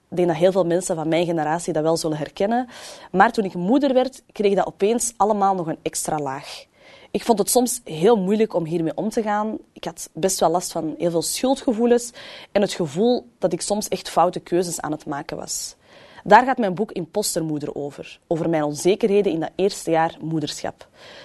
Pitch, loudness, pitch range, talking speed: 185 Hz, -21 LUFS, 165-215 Hz, 205 wpm